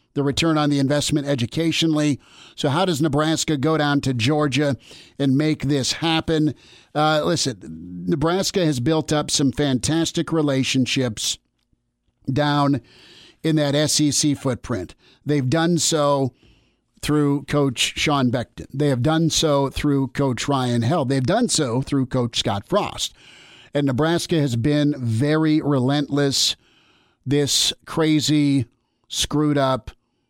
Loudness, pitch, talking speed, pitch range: -20 LUFS, 145 Hz, 125 wpm, 135-155 Hz